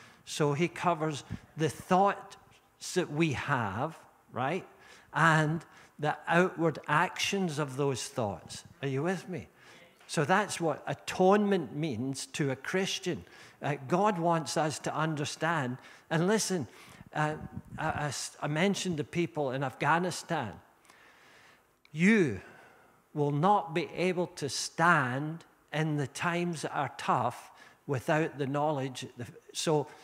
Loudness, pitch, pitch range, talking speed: -31 LUFS, 155 Hz, 145-175 Hz, 125 wpm